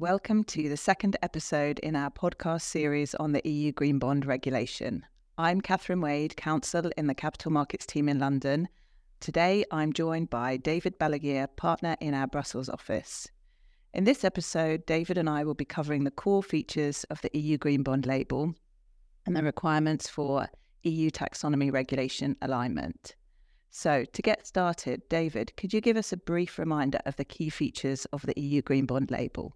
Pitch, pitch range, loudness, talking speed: 150 Hz, 140-165 Hz, -30 LUFS, 175 wpm